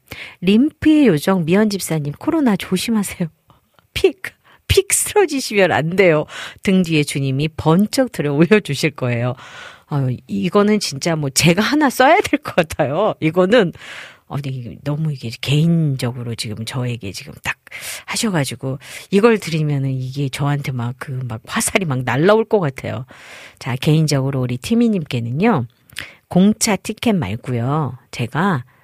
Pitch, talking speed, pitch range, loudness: 155 Hz, 295 characters per minute, 130-205 Hz, -18 LUFS